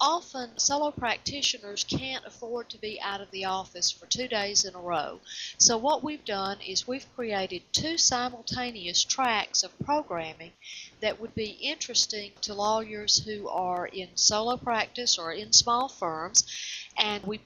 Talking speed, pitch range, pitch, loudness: 160 wpm, 190-245 Hz, 210 Hz, -27 LUFS